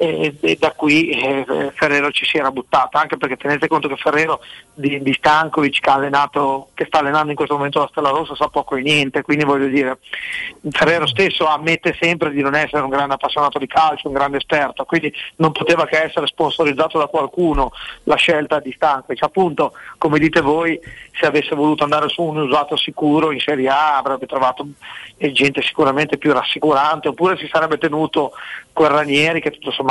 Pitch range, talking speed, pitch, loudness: 140-155 Hz, 185 wpm, 150 Hz, -17 LUFS